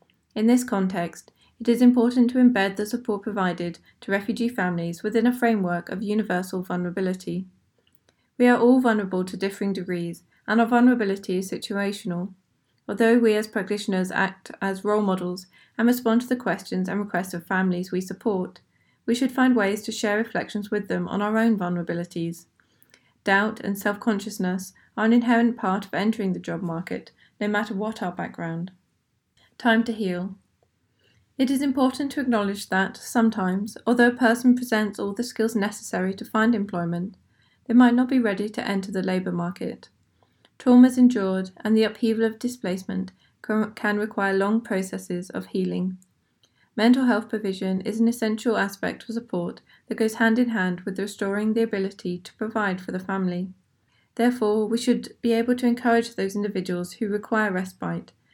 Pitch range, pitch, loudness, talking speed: 185-230 Hz, 210 Hz, -24 LUFS, 165 wpm